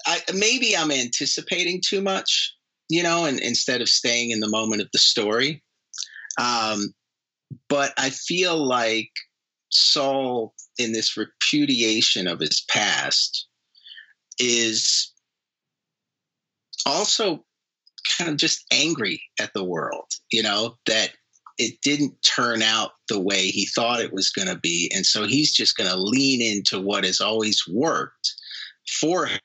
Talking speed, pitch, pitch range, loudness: 140 wpm, 125 Hz, 110-150 Hz, -21 LUFS